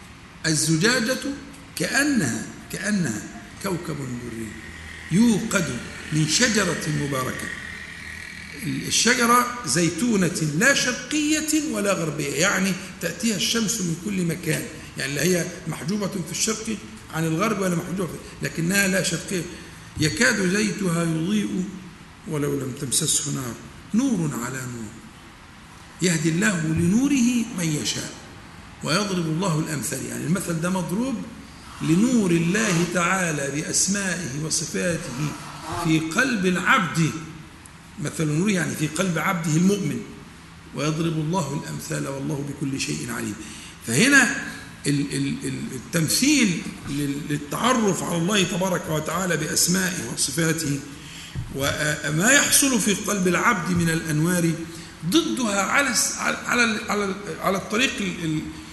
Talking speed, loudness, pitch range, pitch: 100 wpm, -23 LUFS, 155-205 Hz, 170 Hz